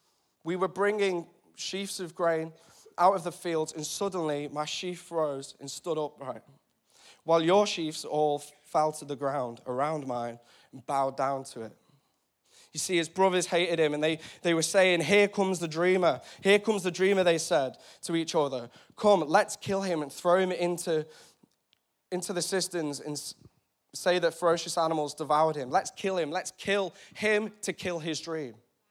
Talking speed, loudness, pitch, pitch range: 175 wpm, -29 LUFS, 170 Hz, 150-185 Hz